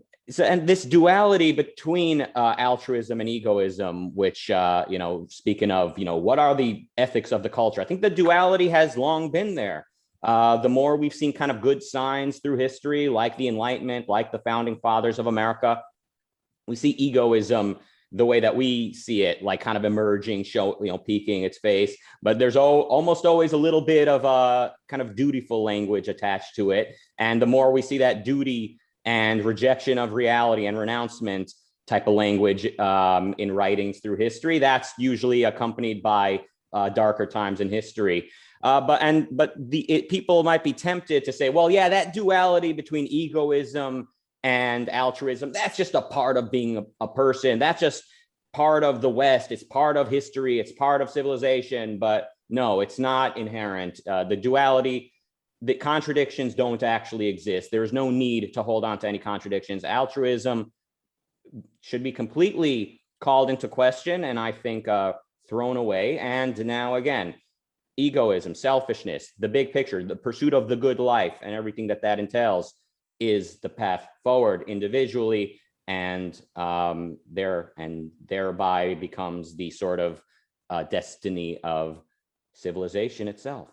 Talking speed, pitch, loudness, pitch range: 170 wpm, 125 Hz, -24 LUFS, 105-140 Hz